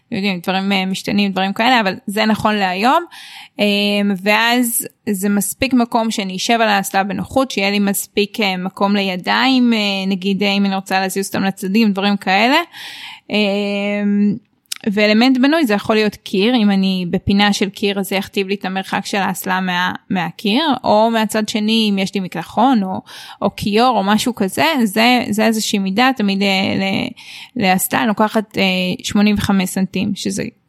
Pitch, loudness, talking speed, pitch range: 205 Hz, -16 LUFS, 150 wpm, 195-225 Hz